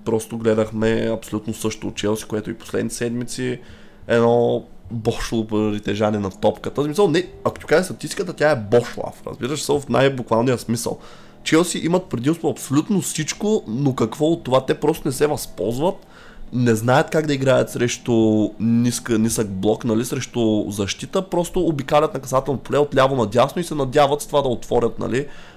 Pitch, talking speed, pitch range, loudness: 120 Hz, 175 wpm, 110-145 Hz, -20 LUFS